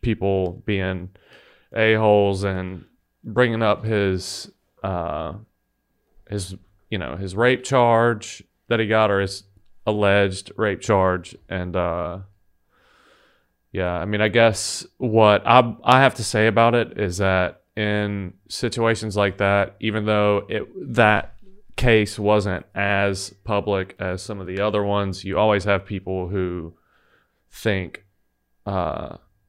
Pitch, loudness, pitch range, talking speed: 100 Hz, -21 LUFS, 95-110 Hz, 130 wpm